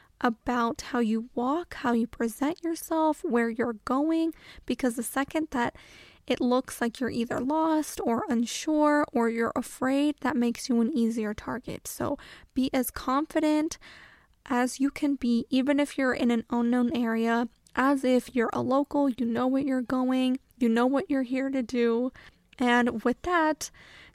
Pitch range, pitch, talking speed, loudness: 240-280 Hz, 255 Hz, 165 wpm, -27 LUFS